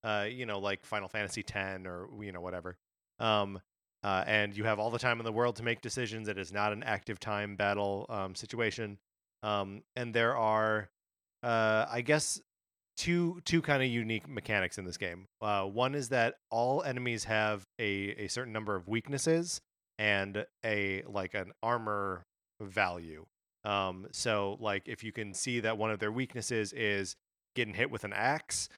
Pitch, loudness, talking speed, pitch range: 105 Hz, -34 LUFS, 180 wpm, 100-115 Hz